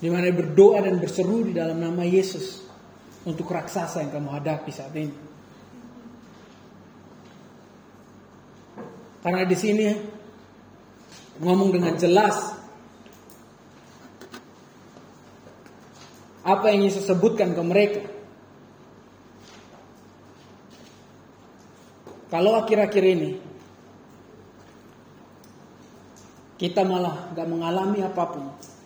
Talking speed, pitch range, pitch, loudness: 75 wpm, 170-210 Hz, 185 Hz, -23 LUFS